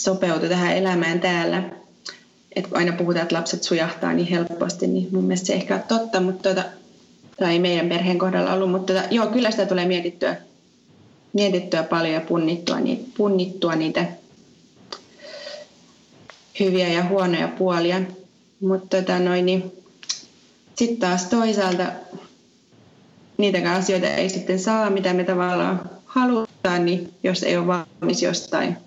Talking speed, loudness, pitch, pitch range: 135 wpm, -22 LUFS, 185 Hz, 180-195 Hz